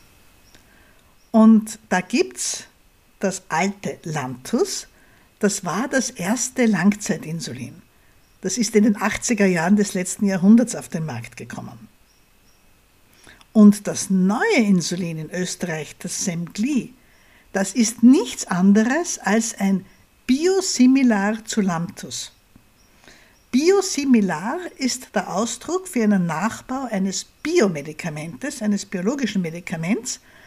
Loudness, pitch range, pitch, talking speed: -20 LUFS, 180-235 Hz, 205 Hz, 105 wpm